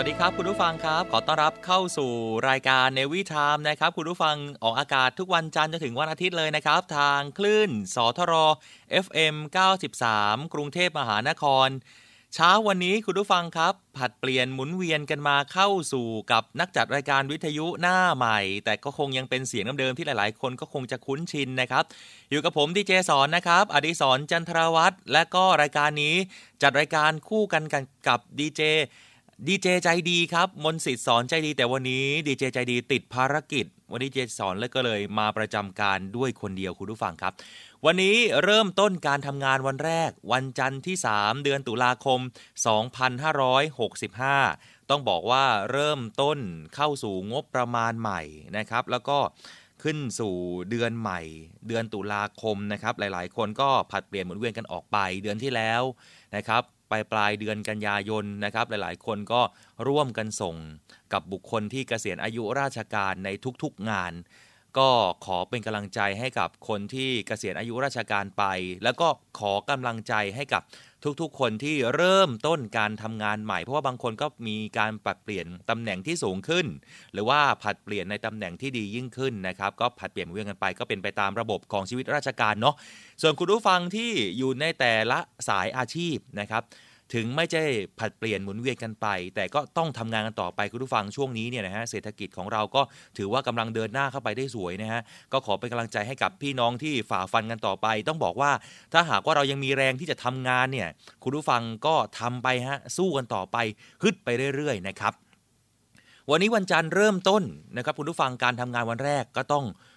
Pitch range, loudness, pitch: 110-150 Hz, -26 LUFS, 130 Hz